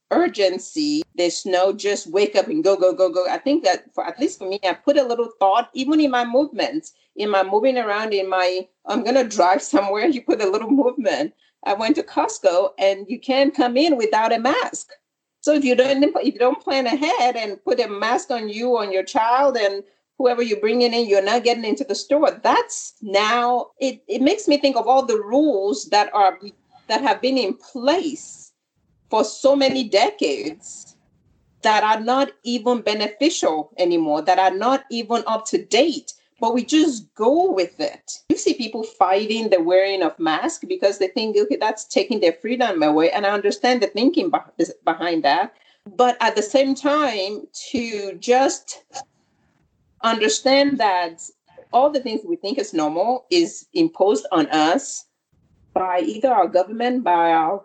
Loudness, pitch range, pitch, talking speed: -20 LUFS, 195-275 Hz, 235 Hz, 180 wpm